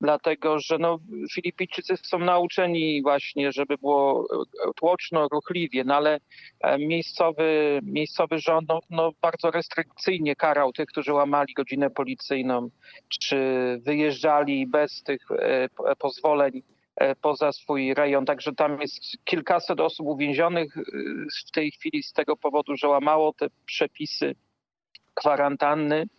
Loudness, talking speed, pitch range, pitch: -25 LUFS, 115 wpm, 145-165 Hz, 150 Hz